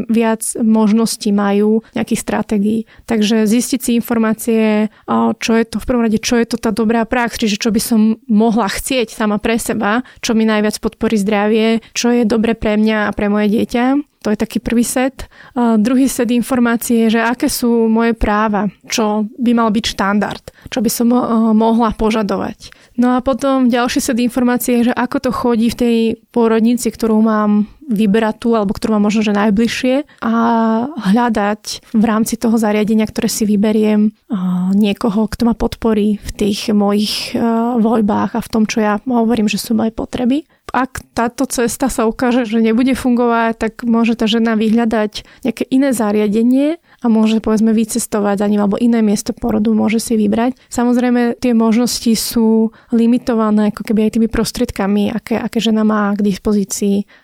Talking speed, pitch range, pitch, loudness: 175 wpm, 215-240 Hz, 225 Hz, -15 LUFS